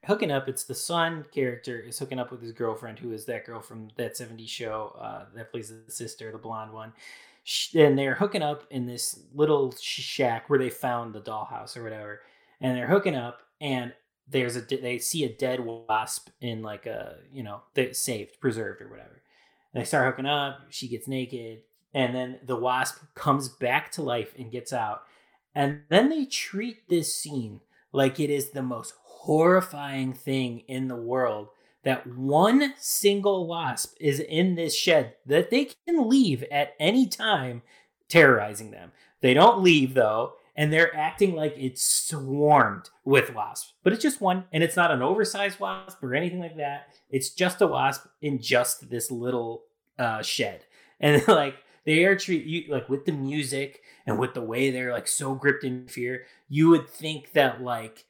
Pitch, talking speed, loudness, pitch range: 135 Hz, 185 wpm, -25 LUFS, 120-160 Hz